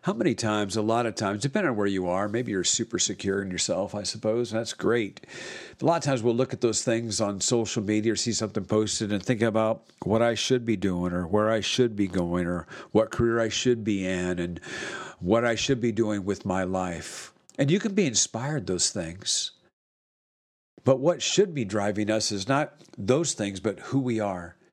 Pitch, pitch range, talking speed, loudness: 110 Hz, 100-120 Hz, 220 wpm, -26 LUFS